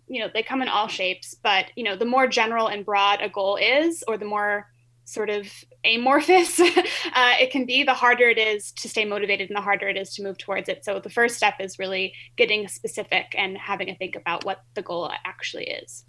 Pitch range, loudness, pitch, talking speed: 195-250 Hz, -22 LUFS, 210 Hz, 230 wpm